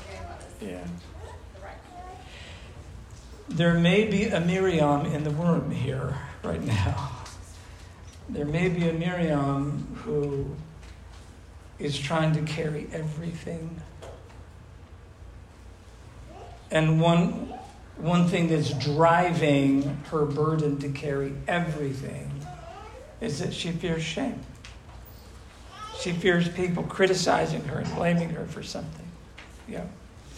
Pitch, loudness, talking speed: 145 Hz, -26 LUFS, 100 wpm